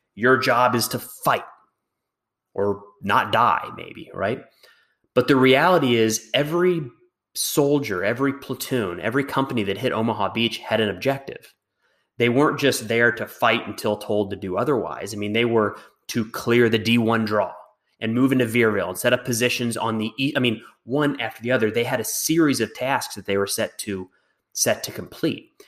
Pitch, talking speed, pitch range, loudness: 120 Hz, 180 wpm, 110-135 Hz, -22 LUFS